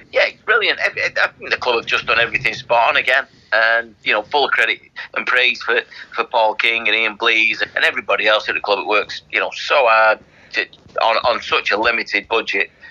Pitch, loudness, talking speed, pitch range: 110 Hz, -16 LUFS, 210 wpm, 110-115 Hz